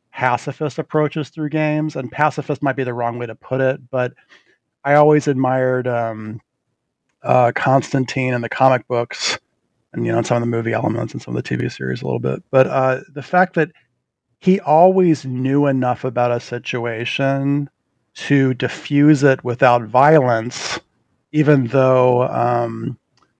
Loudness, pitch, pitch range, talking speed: -18 LUFS, 130 Hz, 120-145 Hz, 160 wpm